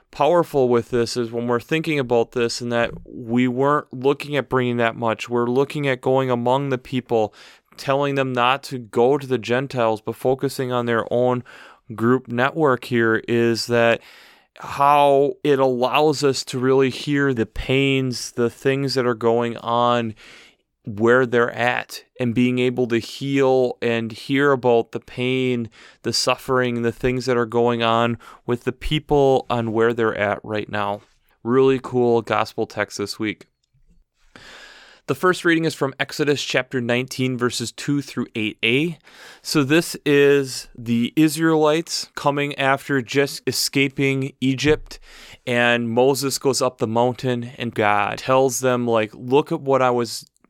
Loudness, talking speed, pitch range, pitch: -20 LUFS, 155 wpm, 120-135 Hz, 125 Hz